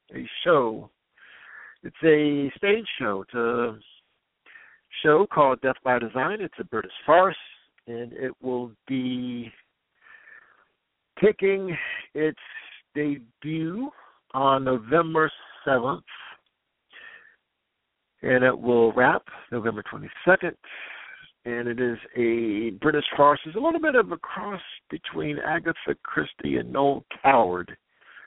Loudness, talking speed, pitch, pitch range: -24 LUFS, 110 wpm, 135 Hz, 120-160 Hz